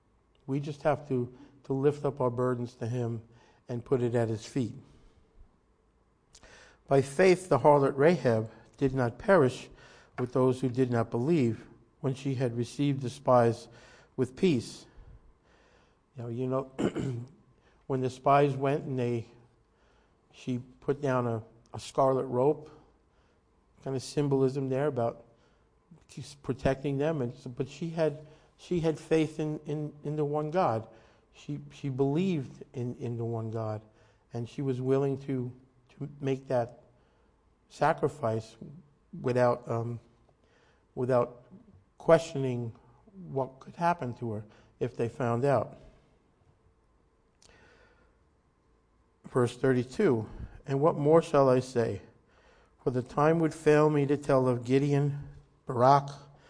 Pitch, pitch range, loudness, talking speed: 130 Hz, 120-145 Hz, -29 LUFS, 135 wpm